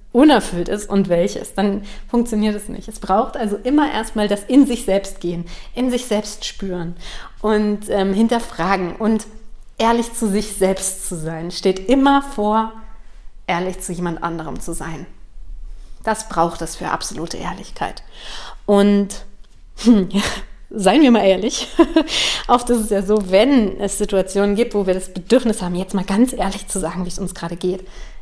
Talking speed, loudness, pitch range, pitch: 170 wpm, -18 LUFS, 185-225 Hz, 205 Hz